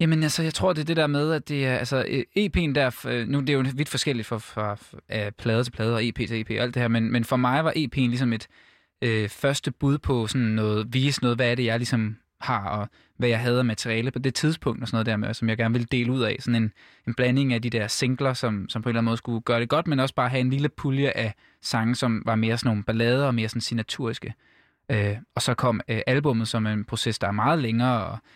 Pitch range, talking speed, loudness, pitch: 115-130 Hz, 275 wpm, -25 LUFS, 120 Hz